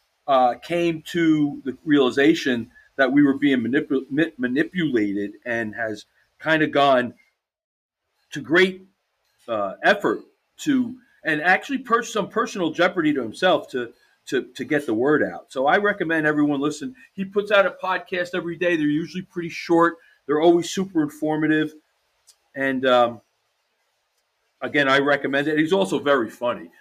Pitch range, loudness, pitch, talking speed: 140-185 Hz, -21 LUFS, 155 Hz, 150 wpm